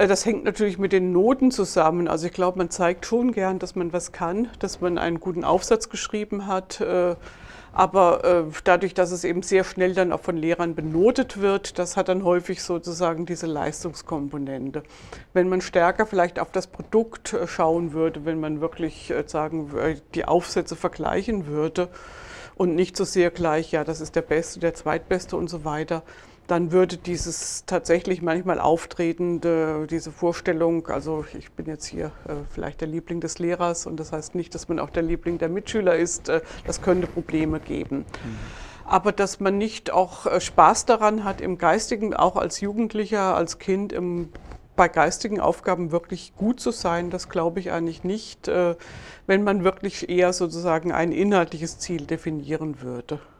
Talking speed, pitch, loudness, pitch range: 165 wpm, 175 Hz, -24 LUFS, 165-190 Hz